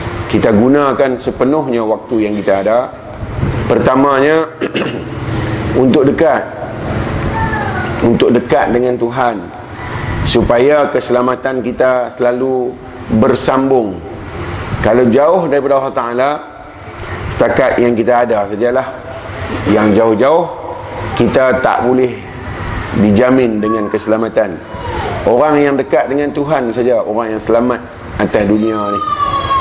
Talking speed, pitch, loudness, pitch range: 100 wpm, 120 Hz, -13 LUFS, 110-130 Hz